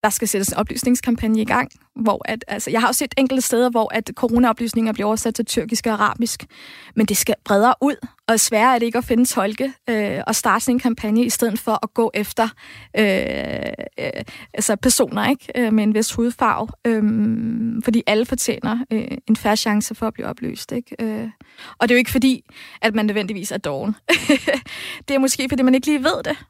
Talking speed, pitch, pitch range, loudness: 215 wpm, 230 Hz, 220-255 Hz, -19 LUFS